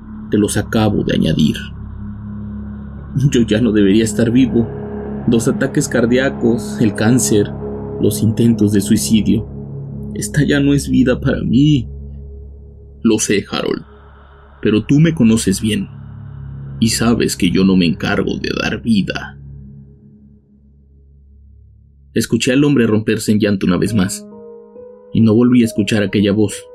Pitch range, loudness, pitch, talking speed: 70-115 Hz, -15 LUFS, 105 Hz, 135 wpm